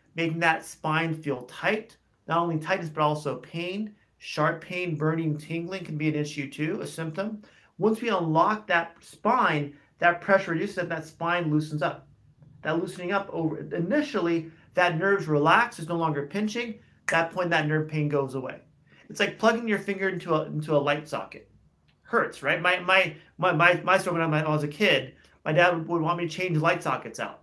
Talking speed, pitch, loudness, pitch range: 195 wpm, 165 Hz, -26 LUFS, 155-185 Hz